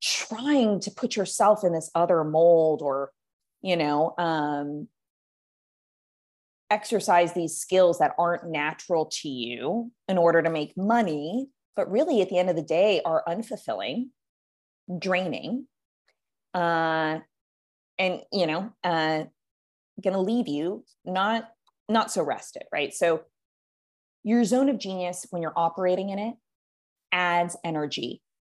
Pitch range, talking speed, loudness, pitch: 160-215 Hz, 130 wpm, -26 LUFS, 180 Hz